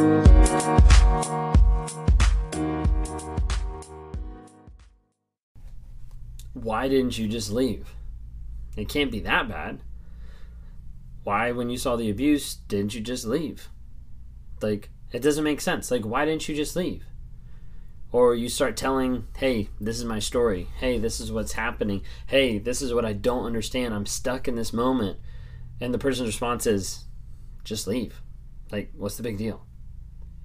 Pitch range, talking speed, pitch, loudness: 80-120 Hz, 135 wpm, 105 Hz, -25 LUFS